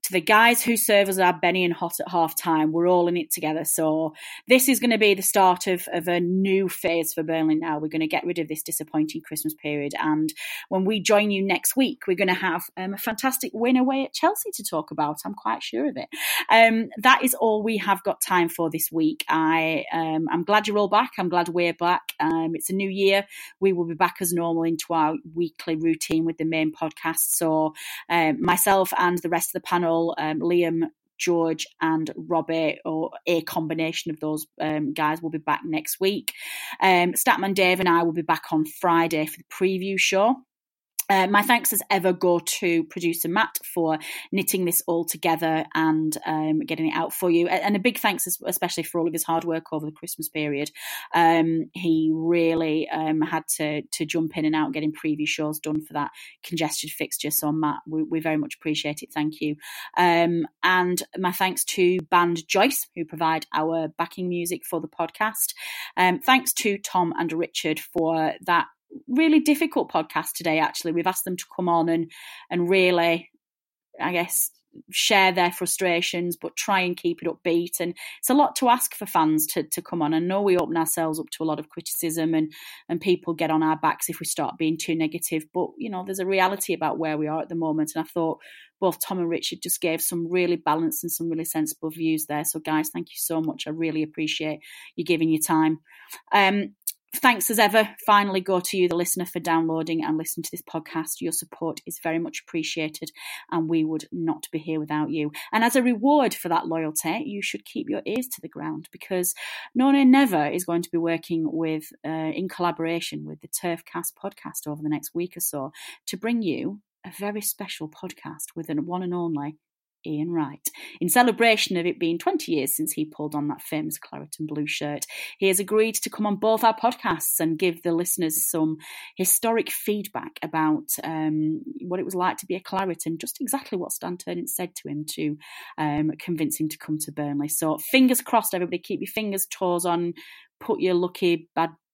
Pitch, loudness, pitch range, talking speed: 170 Hz, -24 LUFS, 160-190 Hz, 210 wpm